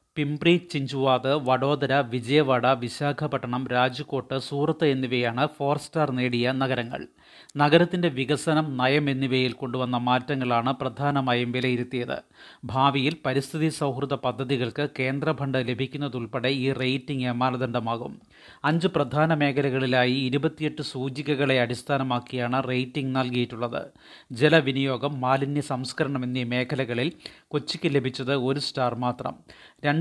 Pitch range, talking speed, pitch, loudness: 125-145 Hz, 95 wpm, 135 Hz, -25 LUFS